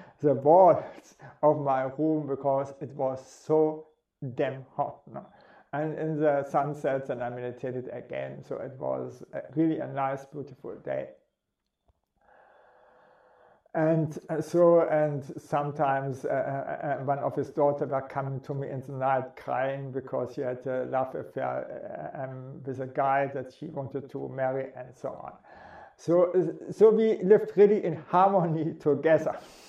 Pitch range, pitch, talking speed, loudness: 135-155 Hz, 140 Hz, 145 wpm, -28 LUFS